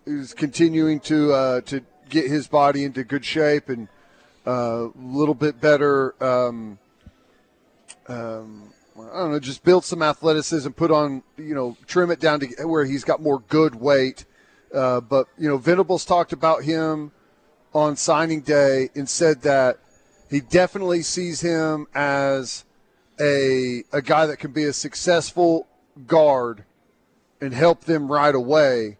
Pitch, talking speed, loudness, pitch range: 145 Hz, 150 wpm, -21 LUFS, 130-160 Hz